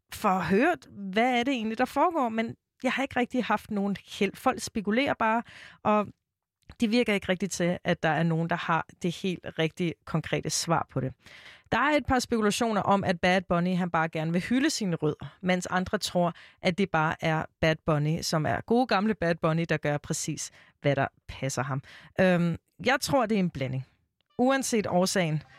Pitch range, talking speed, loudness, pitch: 160-225 Hz, 200 wpm, -28 LUFS, 180 Hz